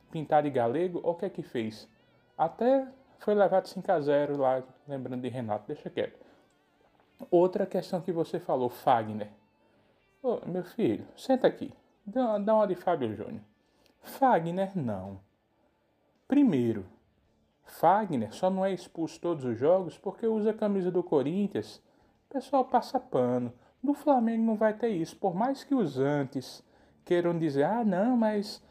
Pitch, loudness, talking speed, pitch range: 180 Hz, -29 LUFS, 150 wpm, 130-220 Hz